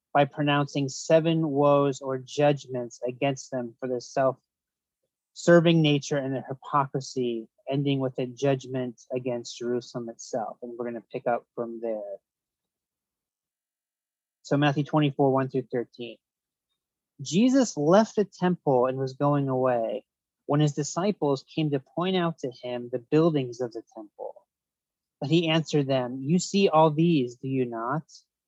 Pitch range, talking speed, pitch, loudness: 125-150 Hz, 145 wpm, 135 Hz, -26 LUFS